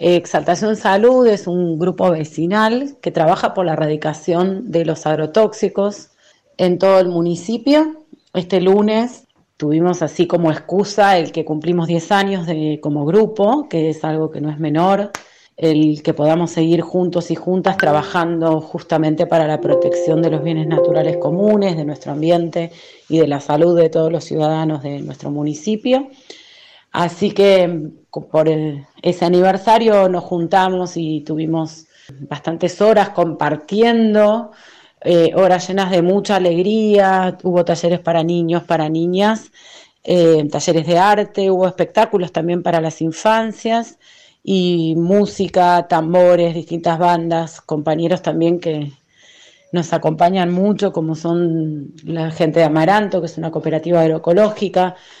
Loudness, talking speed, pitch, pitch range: -16 LUFS, 140 wpm, 175 Hz, 160-195 Hz